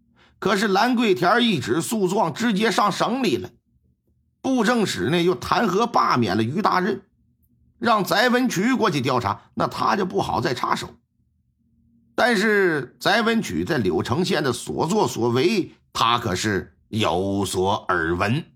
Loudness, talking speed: -21 LUFS, 210 characters per minute